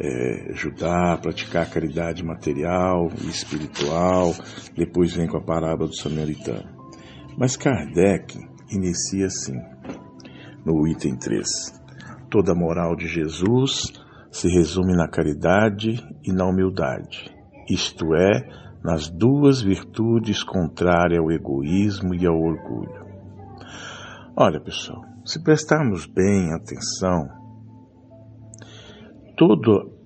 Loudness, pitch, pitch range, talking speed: -22 LUFS, 90 Hz, 80-110 Hz, 100 wpm